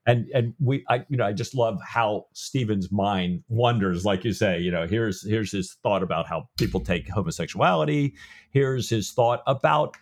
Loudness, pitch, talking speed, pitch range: -25 LUFS, 115 Hz, 185 wpm, 100-130 Hz